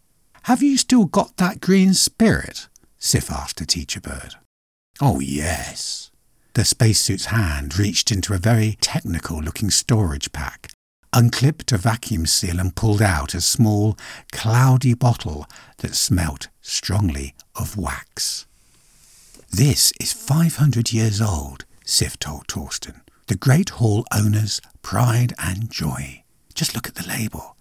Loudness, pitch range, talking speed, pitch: -20 LUFS, 90-130 Hz, 130 wpm, 110 Hz